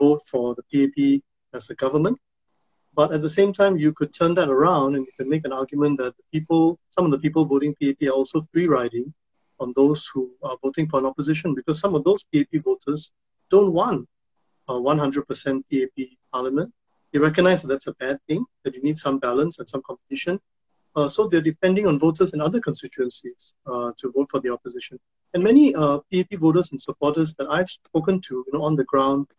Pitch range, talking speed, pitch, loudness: 135-165 Hz, 210 wpm, 145 Hz, -22 LUFS